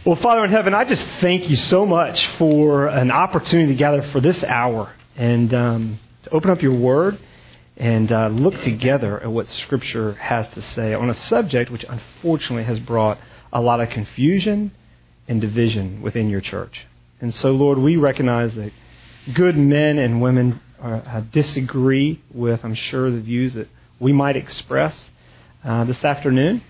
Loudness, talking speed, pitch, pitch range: -19 LUFS, 170 wpm, 125 Hz, 115-145 Hz